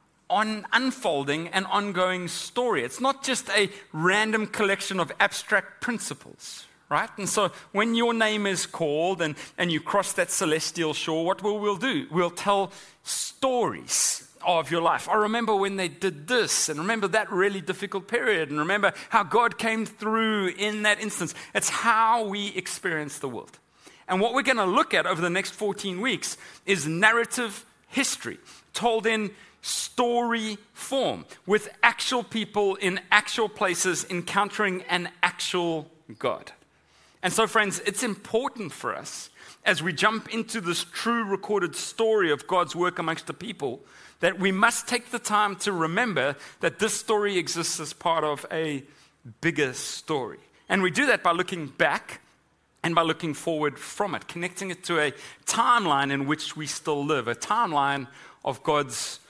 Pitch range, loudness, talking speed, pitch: 170-220 Hz, -25 LUFS, 165 wpm, 195 Hz